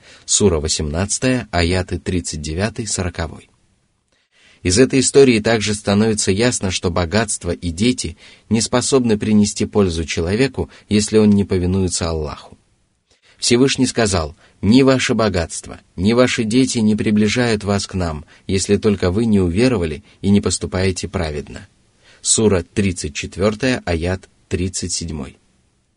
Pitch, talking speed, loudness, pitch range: 100 Hz, 115 wpm, -17 LUFS, 90-110 Hz